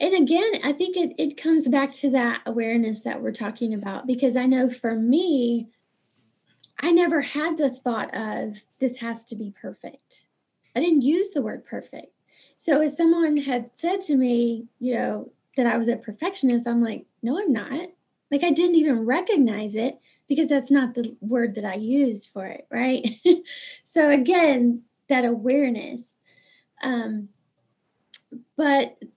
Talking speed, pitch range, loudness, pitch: 165 wpm, 235-300 Hz, -23 LUFS, 260 Hz